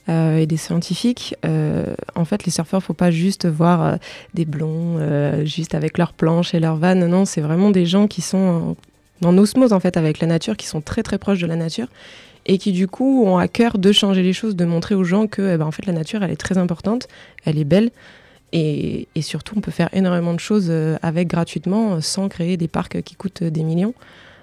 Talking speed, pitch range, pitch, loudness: 235 wpm, 165-195 Hz, 175 Hz, -19 LUFS